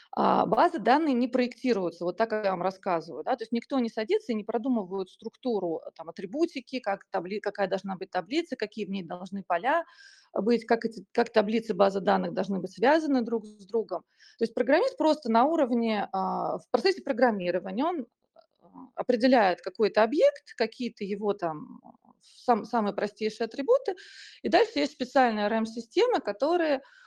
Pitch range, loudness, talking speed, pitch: 200-265 Hz, -28 LUFS, 160 wpm, 230 Hz